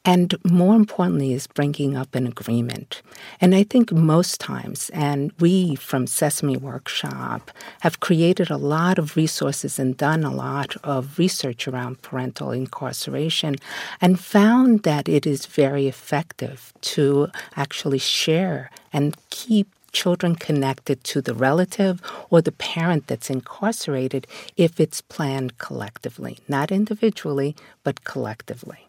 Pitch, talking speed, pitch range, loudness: 150 Hz, 130 wpm, 135-180 Hz, -22 LUFS